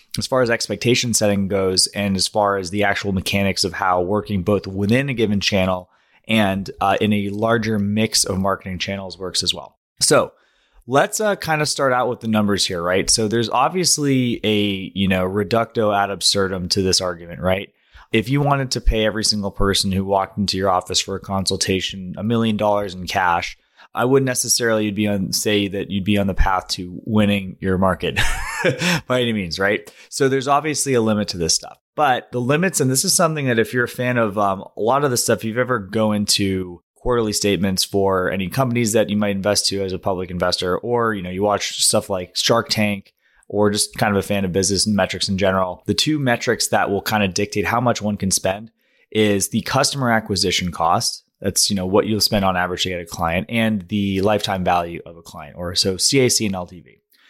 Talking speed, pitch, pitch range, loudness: 220 wpm, 105 Hz, 95-115 Hz, -19 LUFS